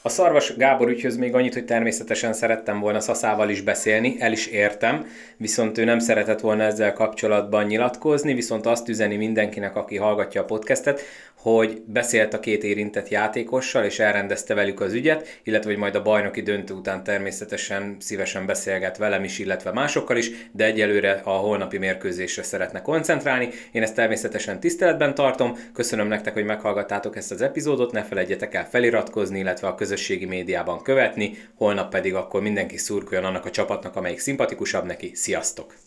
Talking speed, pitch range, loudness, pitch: 165 wpm, 105-115 Hz, -23 LUFS, 110 Hz